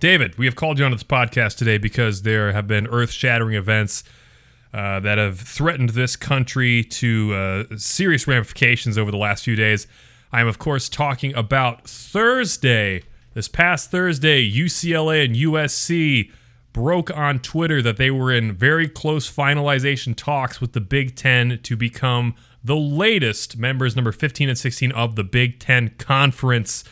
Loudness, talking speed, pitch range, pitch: -19 LUFS, 165 wpm, 115-140 Hz, 125 Hz